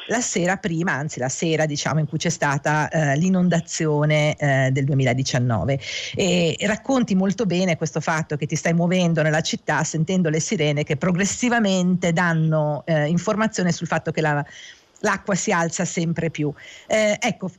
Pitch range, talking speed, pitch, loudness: 150-185 Hz, 165 wpm, 165 Hz, -21 LUFS